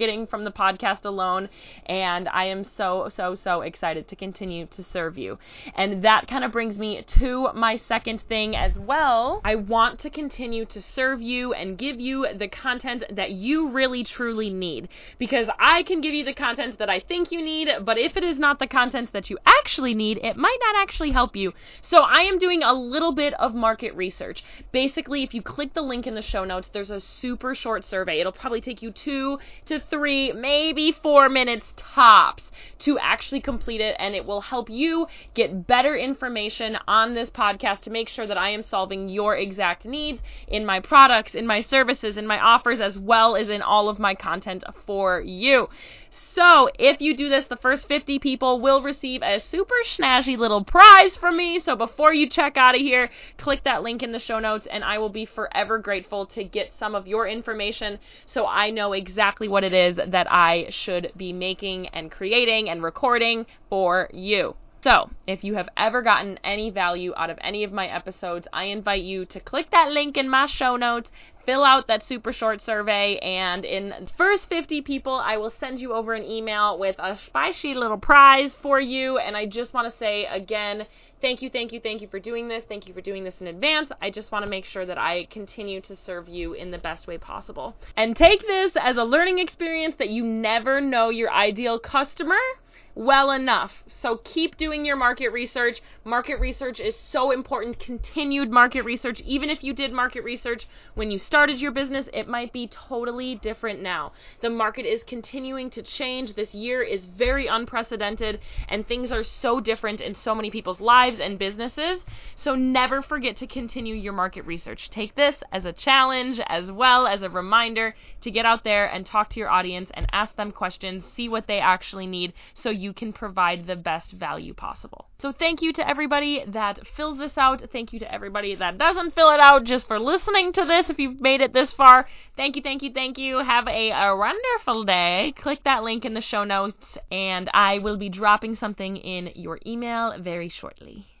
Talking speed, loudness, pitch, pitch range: 205 wpm, -21 LUFS, 230 Hz, 200-270 Hz